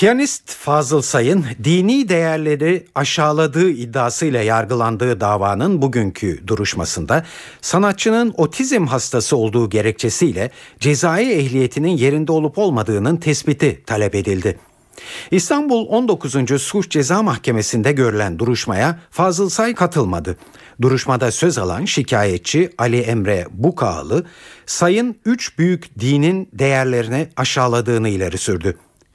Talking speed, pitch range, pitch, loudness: 100 wpm, 115-175 Hz, 140 Hz, -17 LUFS